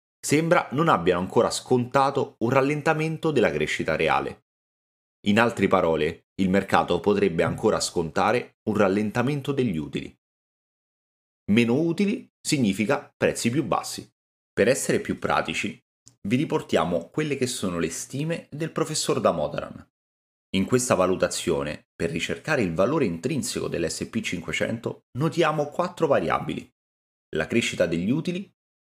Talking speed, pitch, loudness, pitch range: 120 wpm, 125 Hz, -24 LUFS, 95-155 Hz